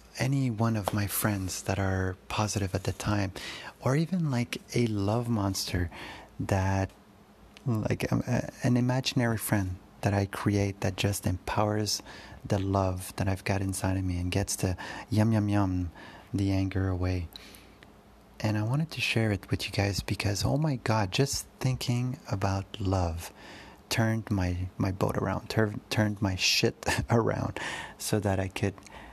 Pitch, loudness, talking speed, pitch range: 100 Hz, -30 LUFS, 160 wpm, 95-110 Hz